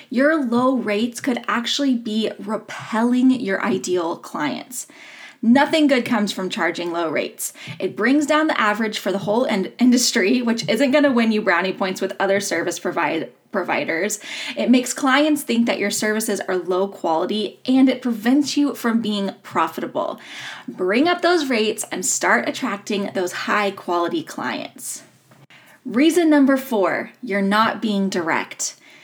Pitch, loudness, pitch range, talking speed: 225 Hz, -20 LUFS, 195-265 Hz, 150 wpm